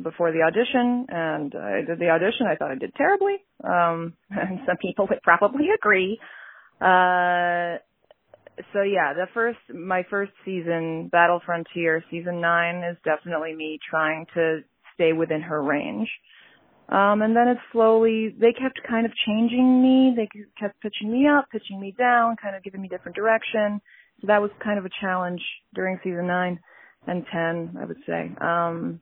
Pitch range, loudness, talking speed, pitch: 170-225 Hz, -23 LUFS, 170 wpm, 185 Hz